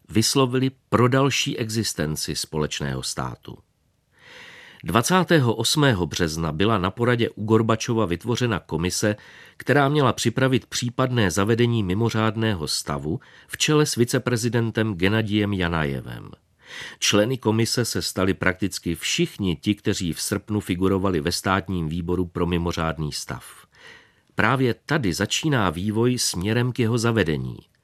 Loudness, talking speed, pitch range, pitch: -22 LUFS, 115 wpm, 90-120 Hz, 110 Hz